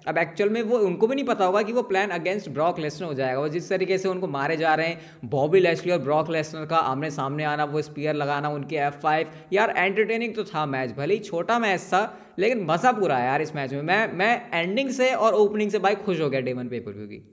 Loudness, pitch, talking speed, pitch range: -24 LUFS, 165 Hz, 255 wpm, 150-200 Hz